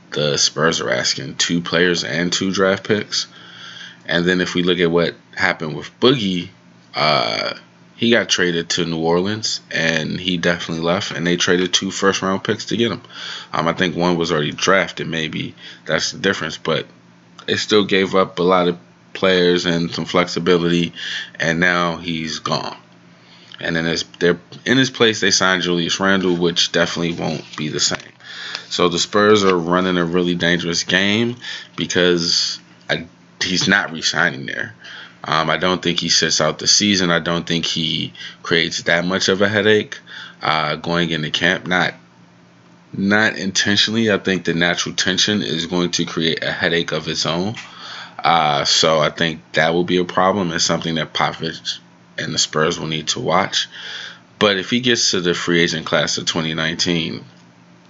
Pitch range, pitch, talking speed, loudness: 85-95 Hz, 85 Hz, 175 wpm, -17 LUFS